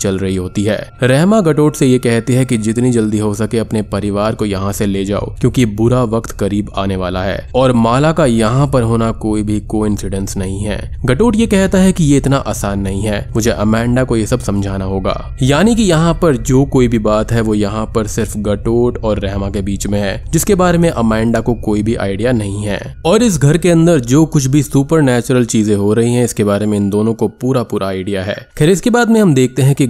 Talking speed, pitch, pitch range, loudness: 235 wpm, 115 Hz, 105-135 Hz, -13 LUFS